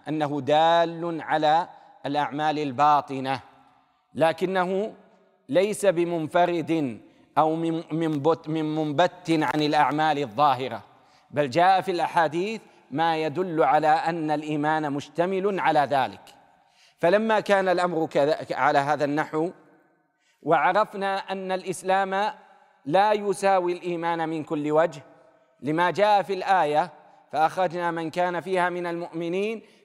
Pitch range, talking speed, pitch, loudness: 155-185 Hz, 110 wpm, 165 Hz, -24 LUFS